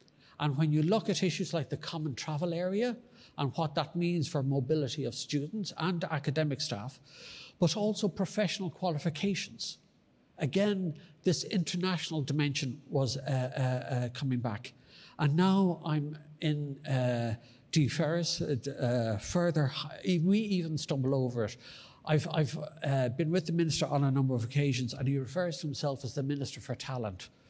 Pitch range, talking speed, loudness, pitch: 135-170 Hz, 155 wpm, -32 LUFS, 150 Hz